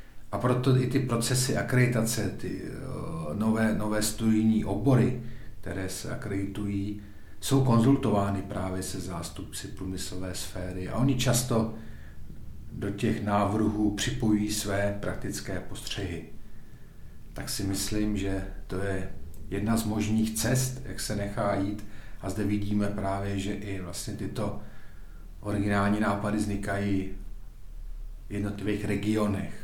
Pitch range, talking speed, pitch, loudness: 95-110 Hz, 120 wpm, 100 Hz, -29 LUFS